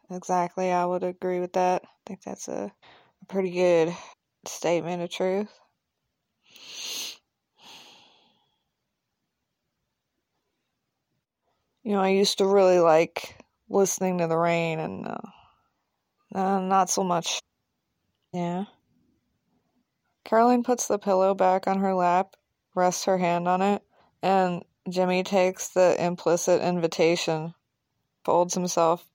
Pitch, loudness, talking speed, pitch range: 180 Hz, -25 LUFS, 115 wpm, 170-190 Hz